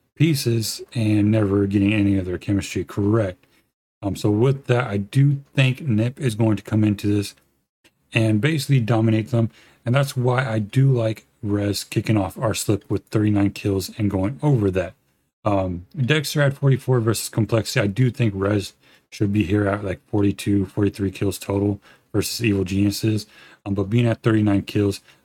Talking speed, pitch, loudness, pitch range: 175 wpm, 105 Hz, -21 LUFS, 100-120 Hz